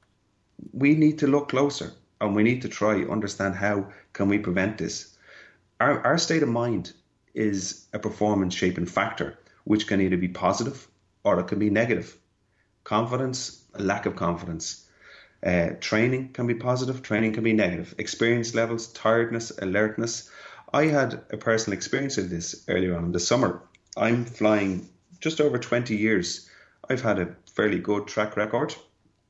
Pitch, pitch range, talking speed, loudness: 110 Hz, 100-120 Hz, 165 wpm, -26 LUFS